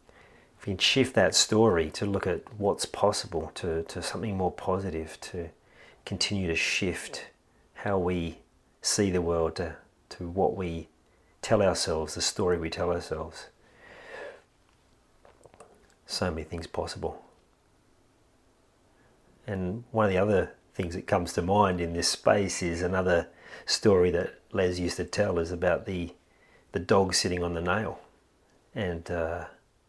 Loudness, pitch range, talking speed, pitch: -28 LUFS, 85-95 Hz, 140 wpm, 90 Hz